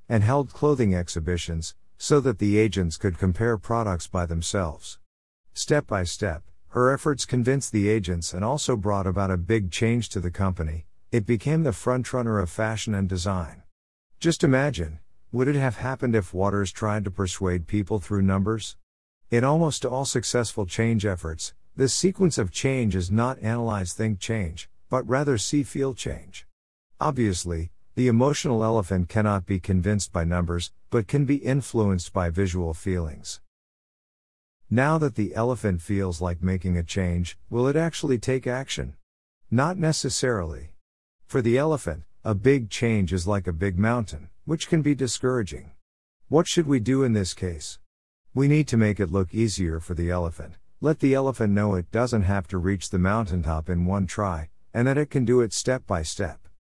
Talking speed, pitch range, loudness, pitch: 170 wpm, 90-125 Hz, -25 LUFS, 100 Hz